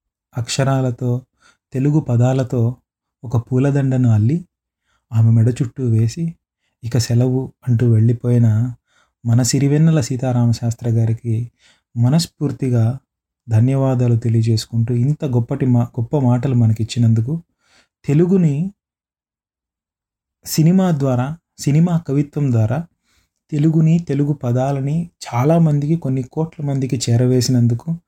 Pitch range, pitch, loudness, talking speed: 120-145 Hz, 125 Hz, -17 LUFS, 90 wpm